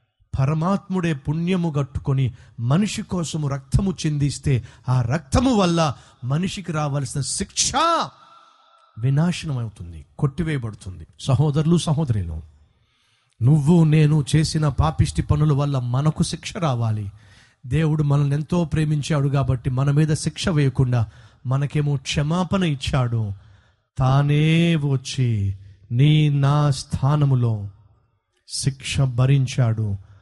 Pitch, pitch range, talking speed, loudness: 140 Hz, 120-155 Hz, 90 wpm, -21 LUFS